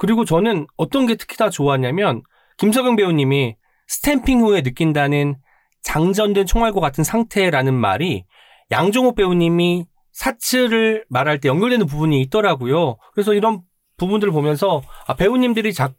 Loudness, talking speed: -18 LUFS, 335 characters per minute